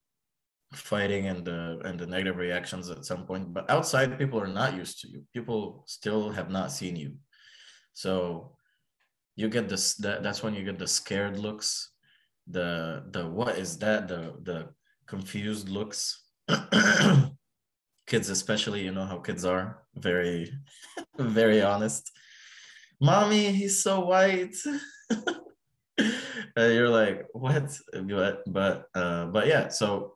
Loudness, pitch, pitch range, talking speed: -28 LUFS, 105 Hz, 95-145 Hz, 140 wpm